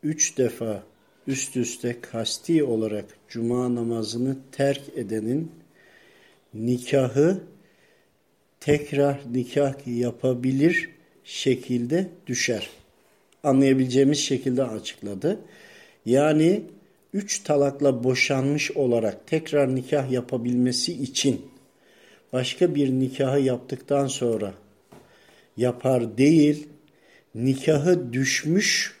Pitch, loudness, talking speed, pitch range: 130 Hz, -24 LUFS, 75 wpm, 120-145 Hz